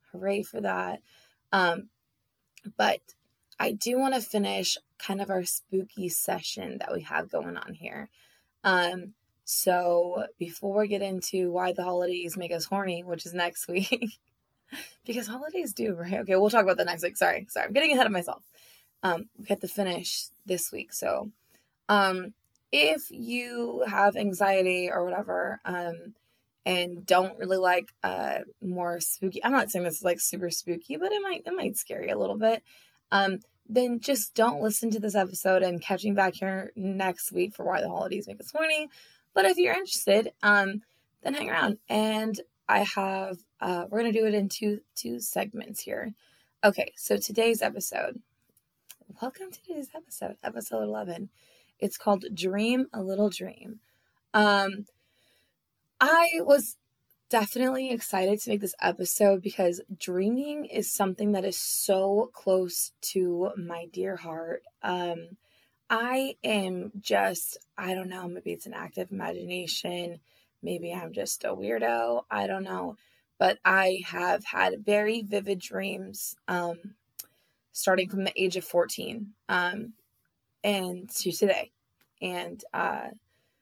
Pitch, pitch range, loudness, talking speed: 195 Hz, 180-220 Hz, -28 LUFS, 155 wpm